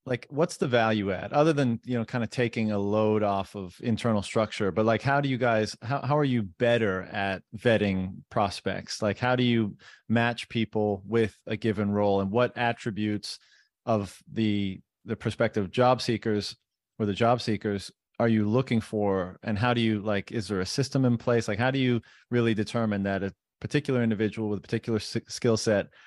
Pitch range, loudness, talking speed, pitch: 105-120 Hz, -27 LUFS, 195 wpm, 110 Hz